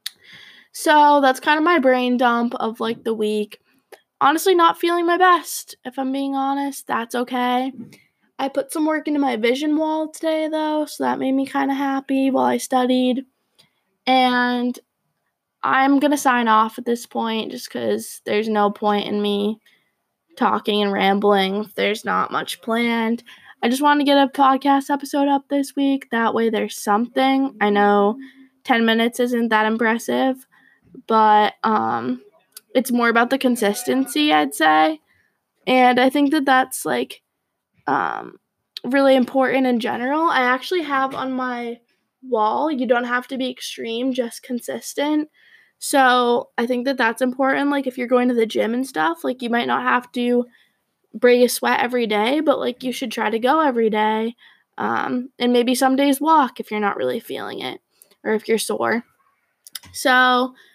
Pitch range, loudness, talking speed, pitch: 225-275 Hz, -19 LUFS, 170 wpm, 255 Hz